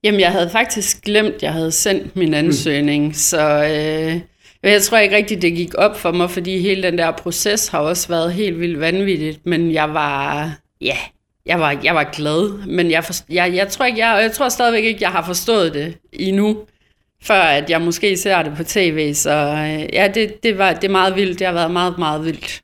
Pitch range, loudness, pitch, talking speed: 155-200 Hz, -16 LUFS, 175 Hz, 215 wpm